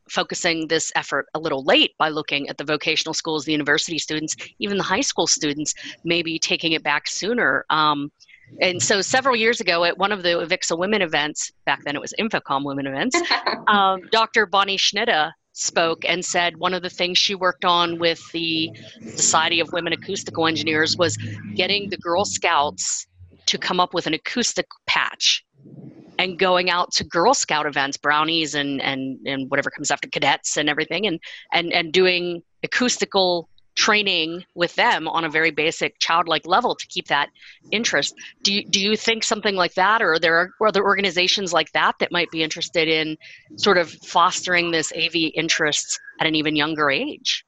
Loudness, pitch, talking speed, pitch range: -20 LUFS, 170 Hz, 185 wpm, 155-185 Hz